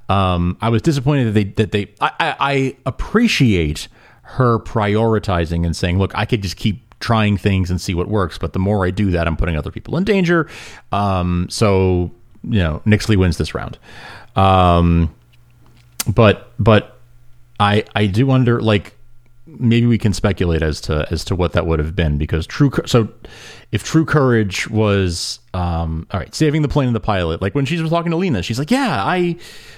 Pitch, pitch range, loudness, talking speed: 105 Hz, 90-120 Hz, -17 LUFS, 190 wpm